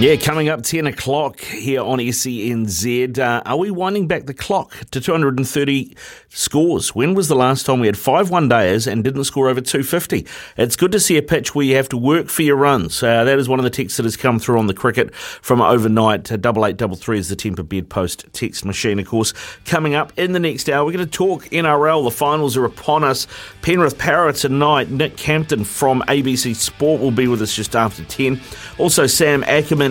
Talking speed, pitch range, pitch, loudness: 230 wpm, 115-150 Hz, 130 Hz, -17 LUFS